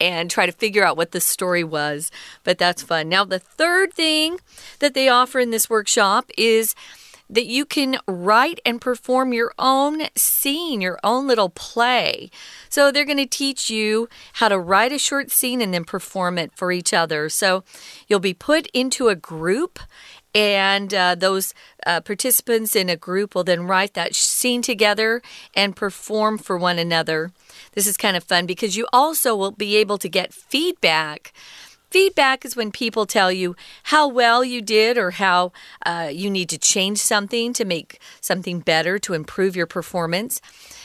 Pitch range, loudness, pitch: 180-250 Hz, -19 LUFS, 210 Hz